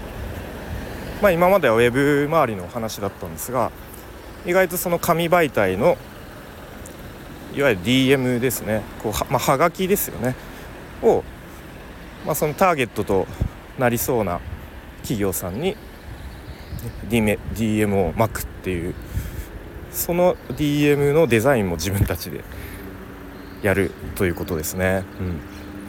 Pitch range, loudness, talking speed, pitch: 95-145 Hz, -21 LUFS, 250 characters per minute, 105 Hz